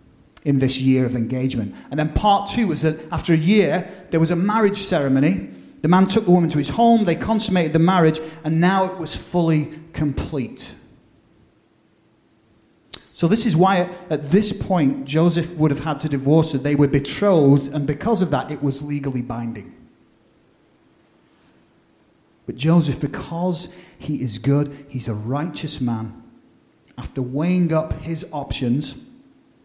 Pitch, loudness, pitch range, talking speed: 155 Hz, -20 LUFS, 140-180 Hz, 155 wpm